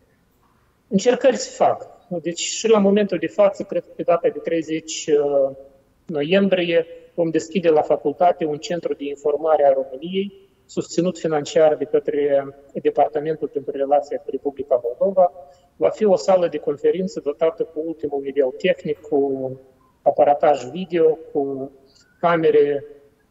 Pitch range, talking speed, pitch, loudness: 145-185 Hz, 135 wpm, 160 Hz, -20 LUFS